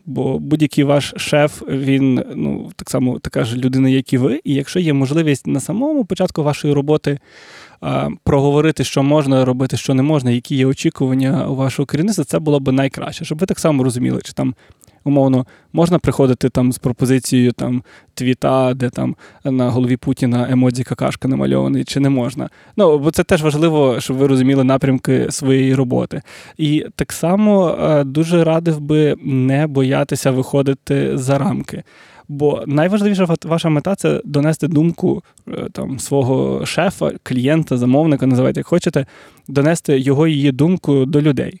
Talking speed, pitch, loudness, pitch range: 160 wpm, 140 Hz, -16 LUFS, 130-155 Hz